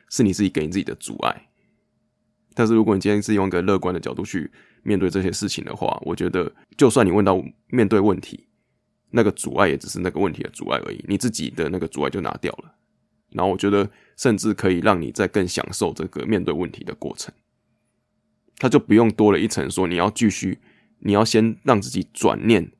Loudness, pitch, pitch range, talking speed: -21 LUFS, 100 Hz, 95-105 Hz, 320 characters per minute